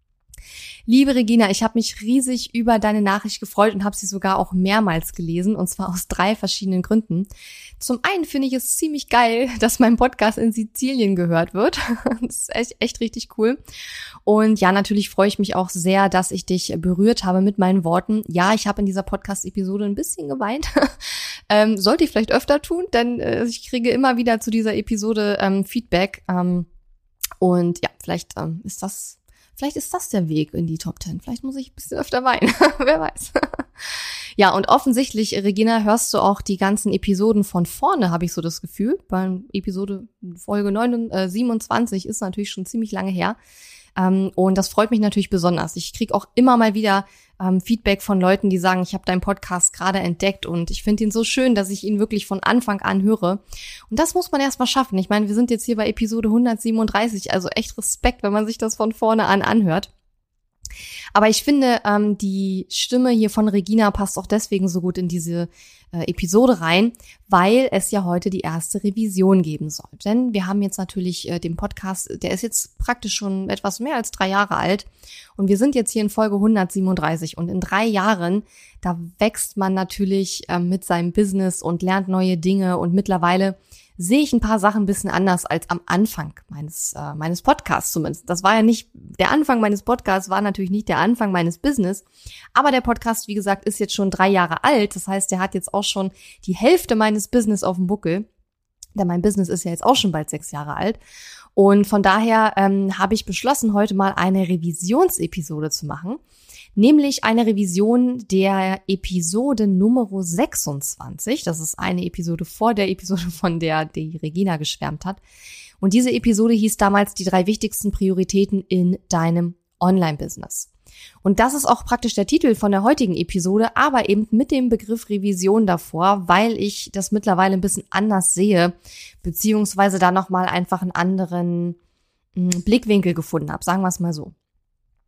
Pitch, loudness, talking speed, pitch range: 200 Hz, -20 LUFS, 190 wpm, 185-225 Hz